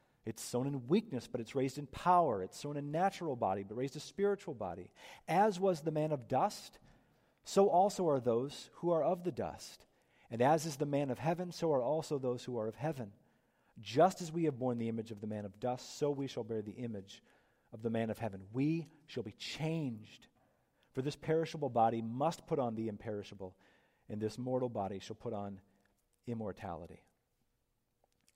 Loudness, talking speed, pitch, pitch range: -36 LUFS, 200 wpm, 125 Hz, 110-160 Hz